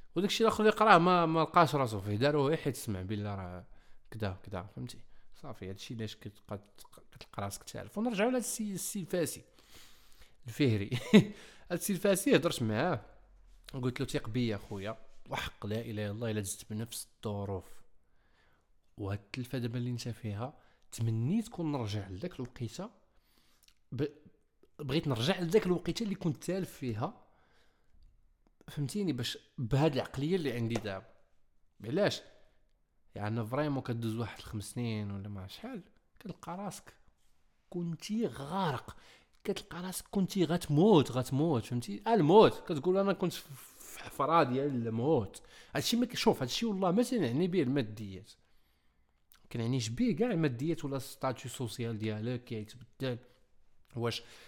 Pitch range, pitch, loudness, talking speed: 105-165 Hz, 125 Hz, -33 LUFS, 135 wpm